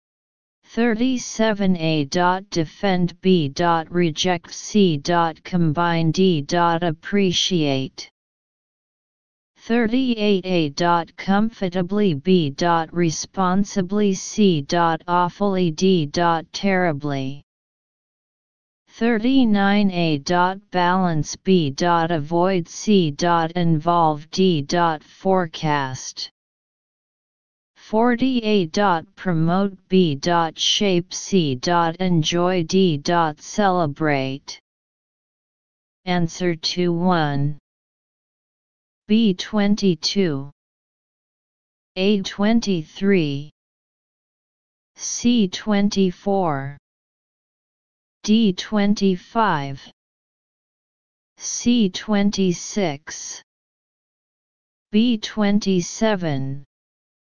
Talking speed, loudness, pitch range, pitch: 55 wpm, -20 LUFS, 165-200 Hz, 180 Hz